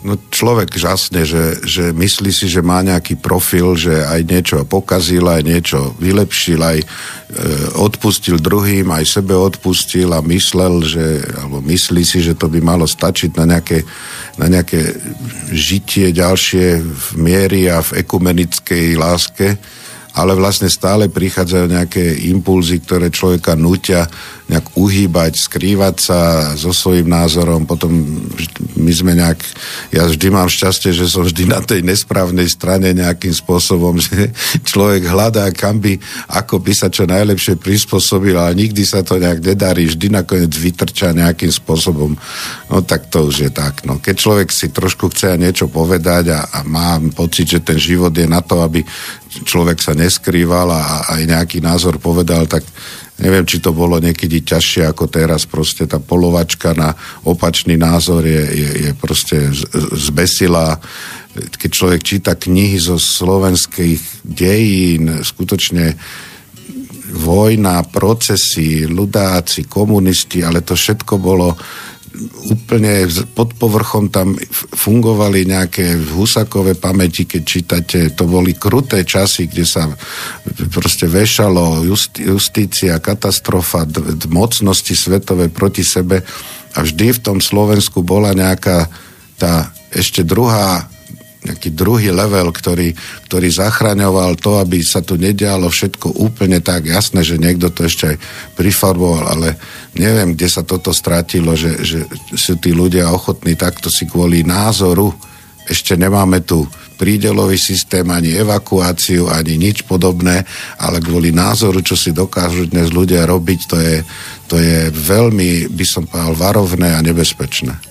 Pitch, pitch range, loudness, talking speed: 90 Hz, 85-95 Hz, -13 LUFS, 140 wpm